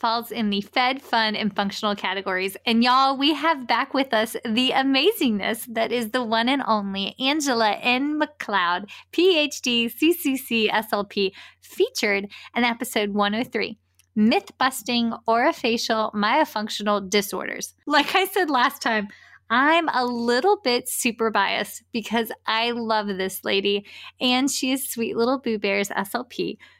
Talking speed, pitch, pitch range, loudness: 140 wpm, 235 Hz, 210-265 Hz, -22 LUFS